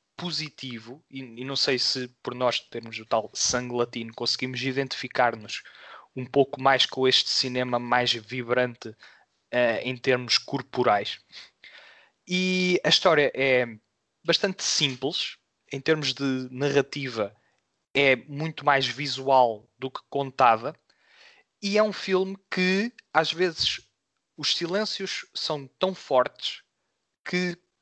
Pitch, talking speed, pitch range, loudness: 135 Hz, 125 wpm, 125-165 Hz, -25 LUFS